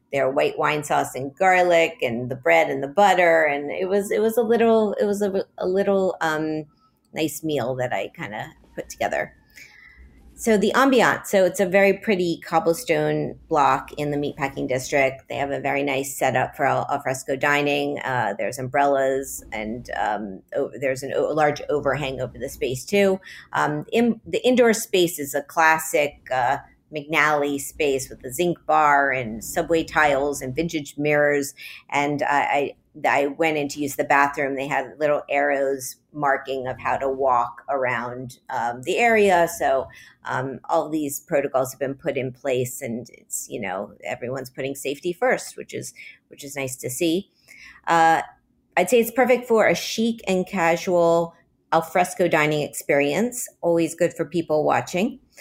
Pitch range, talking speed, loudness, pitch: 135-175 Hz, 175 wpm, -22 LUFS, 150 Hz